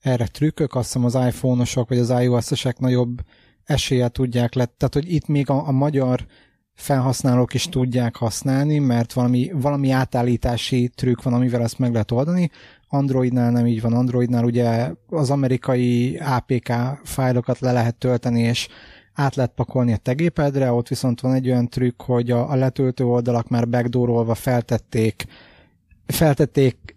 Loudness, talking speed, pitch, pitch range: -20 LUFS, 150 wpm, 125 Hz, 120-130 Hz